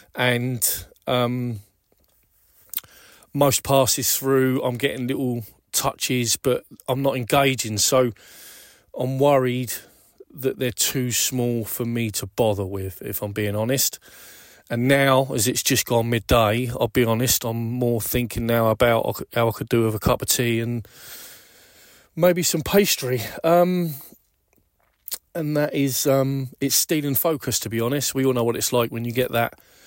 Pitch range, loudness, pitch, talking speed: 115-135 Hz, -22 LUFS, 125 Hz, 155 wpm